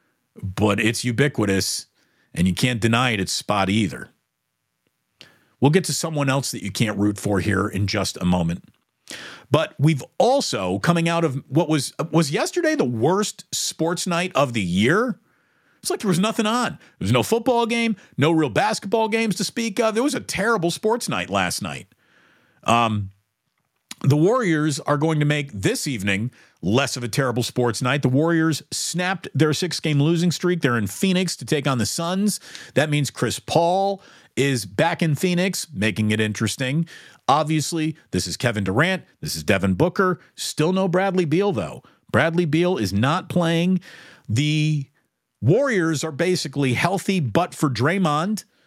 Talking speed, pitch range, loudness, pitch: 170 wpm, 120-180 Hz, -21 LUFS, 155 Hz